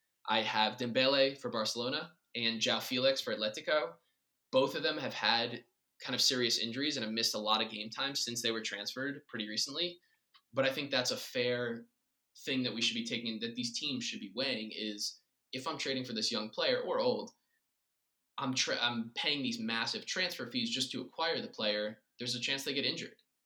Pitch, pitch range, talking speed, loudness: 130 Hz, 115-175 Hz, 205 wpm, -34 LUFS